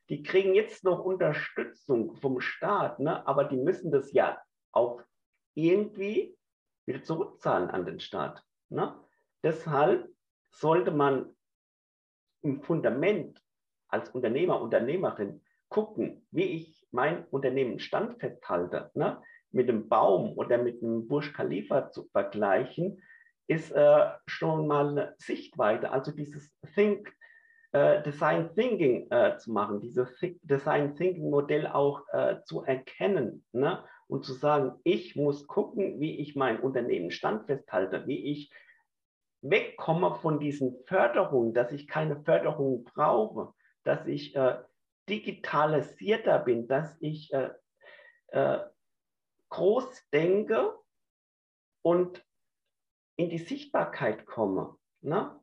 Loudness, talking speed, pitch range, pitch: -29 LUFS, 120 wpm, 145-220 Hz, 165 Hz